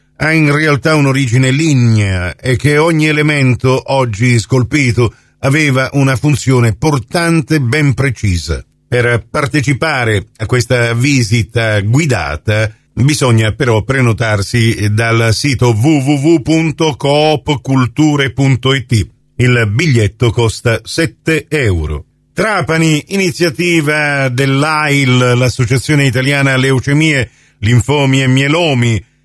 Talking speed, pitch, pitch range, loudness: 90 wpm, 135 Hz, 120-150 Hz, -12 LUFS